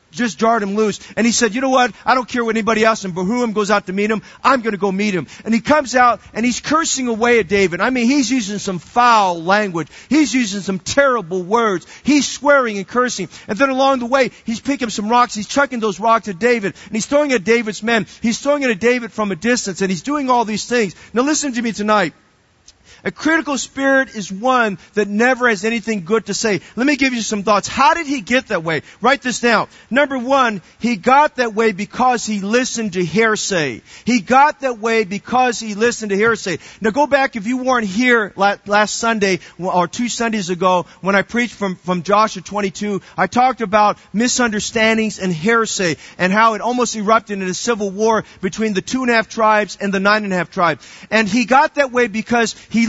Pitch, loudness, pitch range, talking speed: 225 Hz, -16 LUFS, 200-245 Hz, 225 wpm